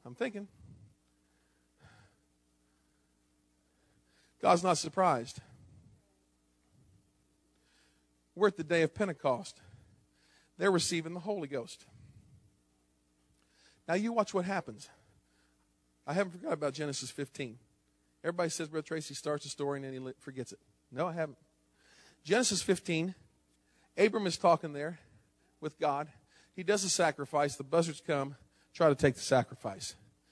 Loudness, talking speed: -33 LUFS, 125 wpm